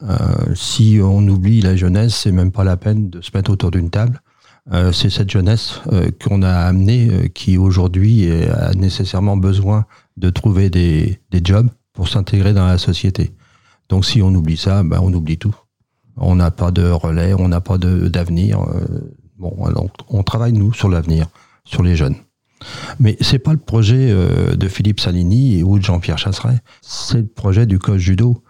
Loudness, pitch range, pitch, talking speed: -15 LUFS, 90-115 Hz, 100 Hz, 190 wpm